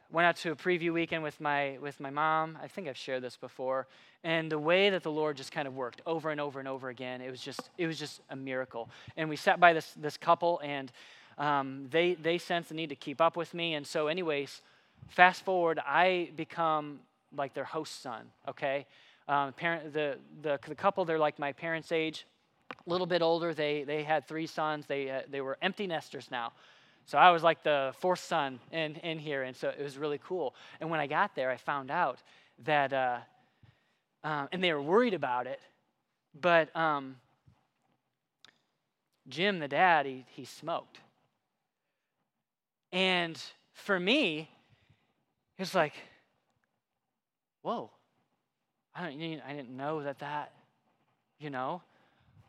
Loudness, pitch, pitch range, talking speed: -32 LUFS, 150 Hz, 140-165 Hz, 180 wpm